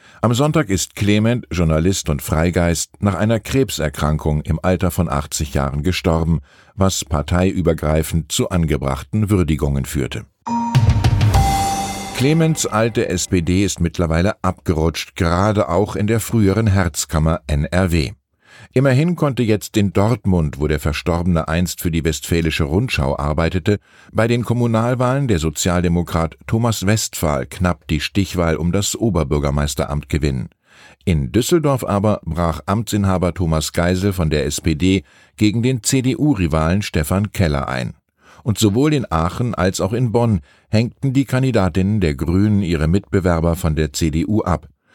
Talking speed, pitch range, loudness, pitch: 130 wpm, 80-110 Hz, -18 LUFS, 90 Hz